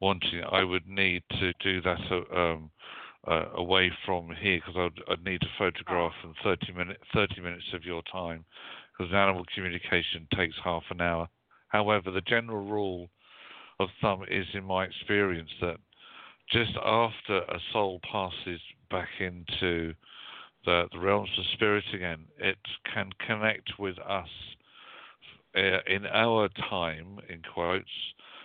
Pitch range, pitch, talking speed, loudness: 85-100 Hz, 95 Hz, 140 wpm, -30 LUFS